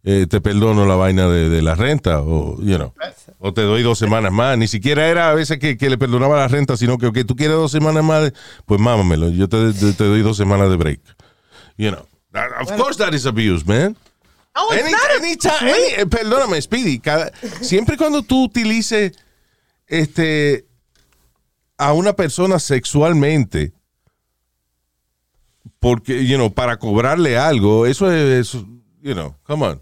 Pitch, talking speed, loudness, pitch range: 125 Hz, 170 wpm, -16 LUFS, 100-155 Hz